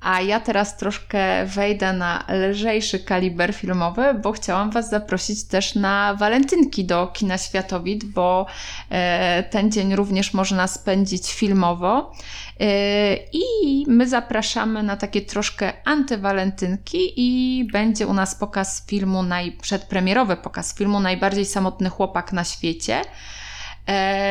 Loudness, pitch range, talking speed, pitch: -21 LUFS, 185-215 Hz, 115 wpm, 195 Hz